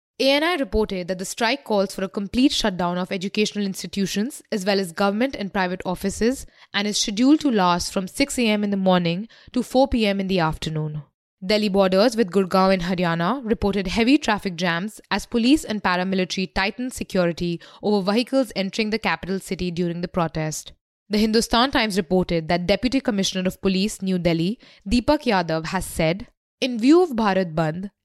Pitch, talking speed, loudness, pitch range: 200 Hz, 175 wpm, -22 LUFS, 185-230 Hz